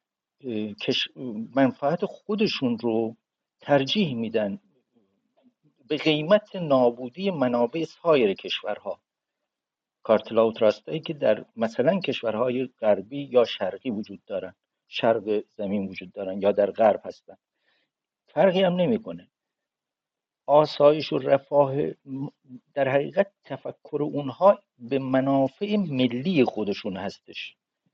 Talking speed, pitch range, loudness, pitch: 100 wpm, 115-160 Hz, -25 LUFS, 135 Hz